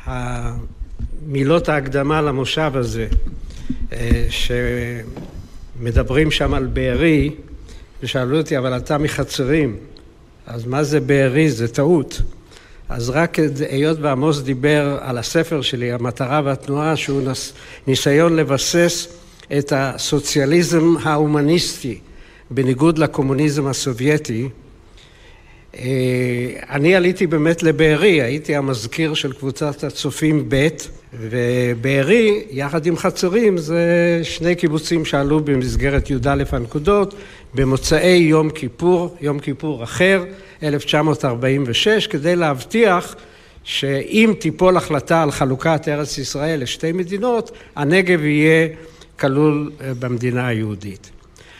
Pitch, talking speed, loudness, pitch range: 145 Hz, 95 wpm, -18 LUFS, 130-160 Hz